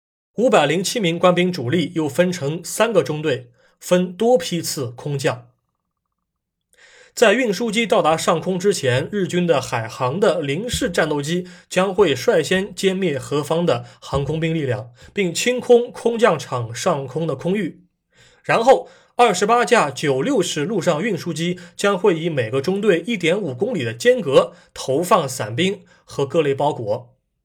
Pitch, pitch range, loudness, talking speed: 170 Hz, 145-195 Hz, -19 LUFS, 230 characters per minute